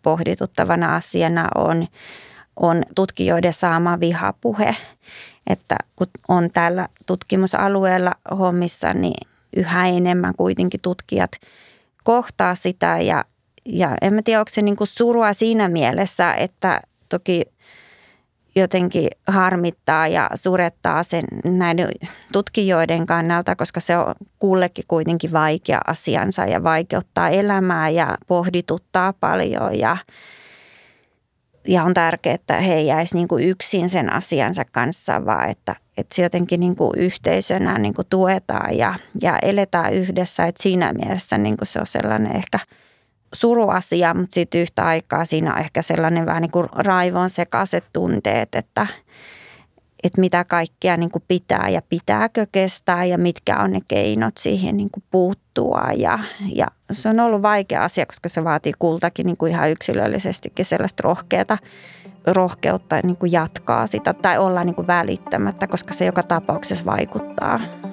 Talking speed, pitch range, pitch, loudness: 135 wpm, 165-190 Hz, 175 Hz, -19 LUFS